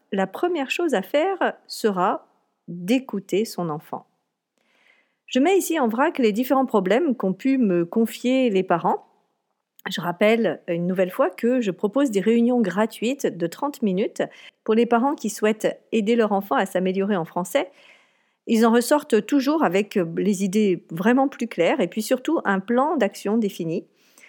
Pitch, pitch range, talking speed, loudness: 225 Hz, 195-260 Hz, 165 wpm, -22 LUFS